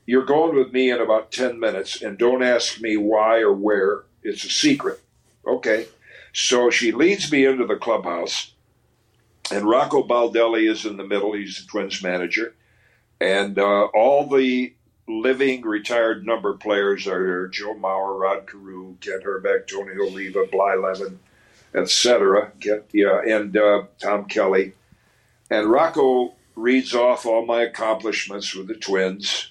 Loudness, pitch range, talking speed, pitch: -21 LUFS, 100-130 Hz, 155 wpm, 110 Hz